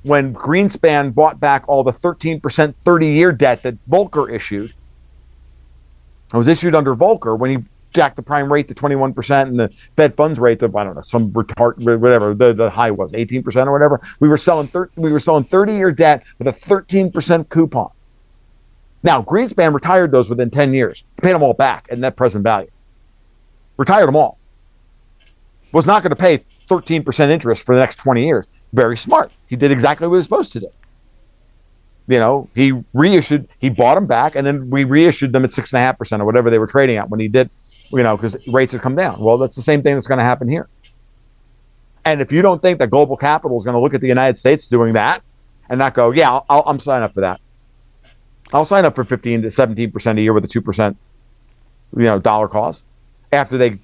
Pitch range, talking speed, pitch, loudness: 115-150 Hz, 210 wpm, 130 Hz, -15 LUFS